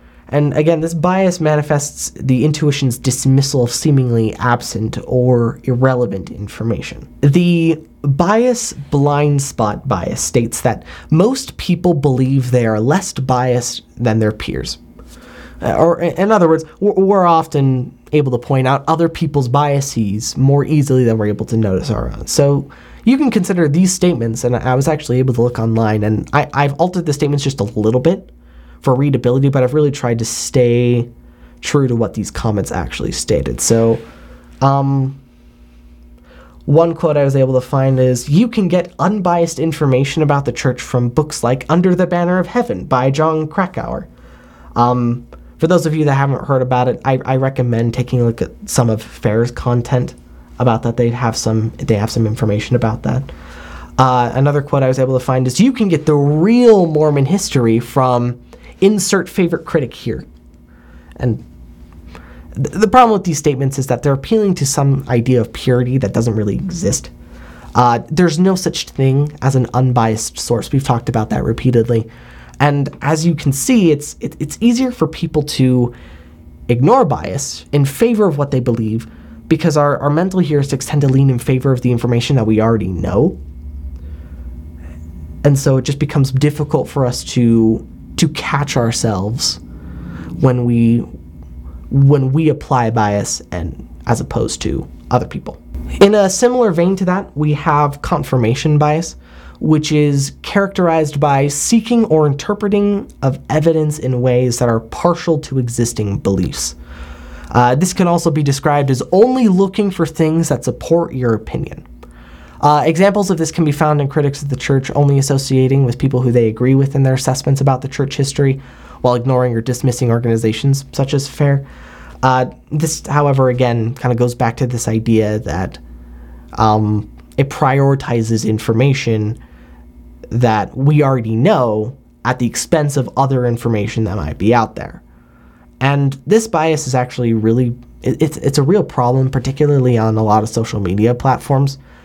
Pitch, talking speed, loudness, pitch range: 130 Hz, 170 wpm, -15 LUFS, 115-150 Hz